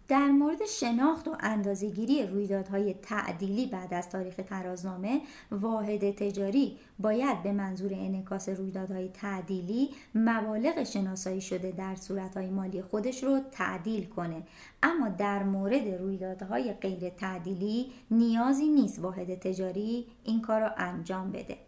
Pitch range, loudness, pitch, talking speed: 190-235 Hz, -31 LUFS, 200 Hz, 120 wpm